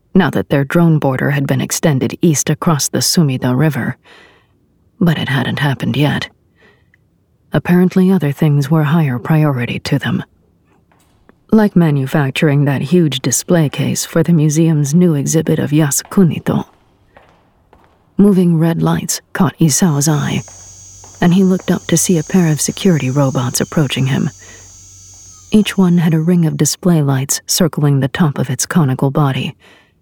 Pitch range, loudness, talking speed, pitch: 135-175 Hz, -14 LUFS, 145 wpm, 155 Hz